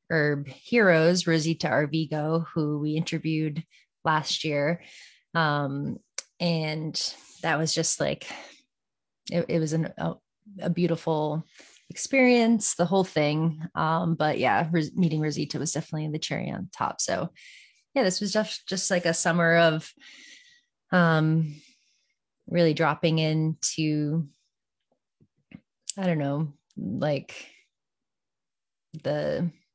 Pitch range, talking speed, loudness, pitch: 155-180 Hz, 115 wpm, -26 LUFS, 165 Hz